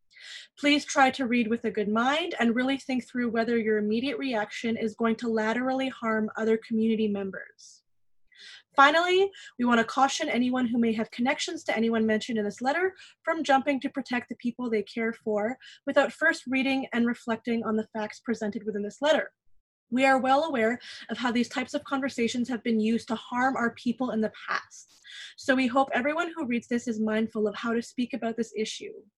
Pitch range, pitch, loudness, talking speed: 225-270 Hz, 240 Hz, -27 LUFS, 200 wpm